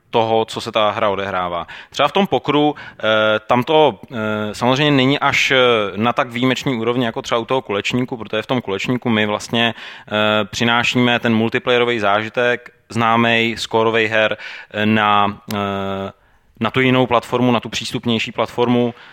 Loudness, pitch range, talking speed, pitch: -17 LUFS, 105-125 Hz, 145 wpm, 115 Hz